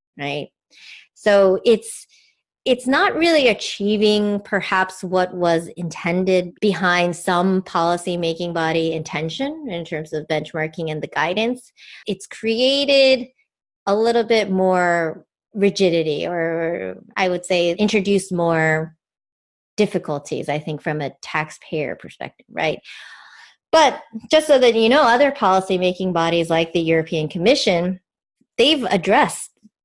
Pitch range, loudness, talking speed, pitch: 165-220 Hz, -19 LUFS, 125 wpm, 185 Hz